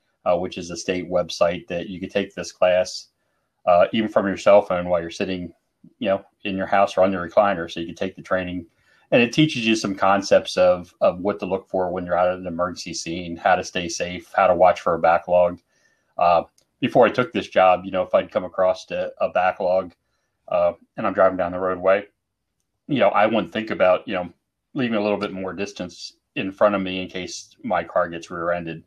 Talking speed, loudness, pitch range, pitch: 230 wpm, -21 LUFS, 90-100 Hz, 95 Hz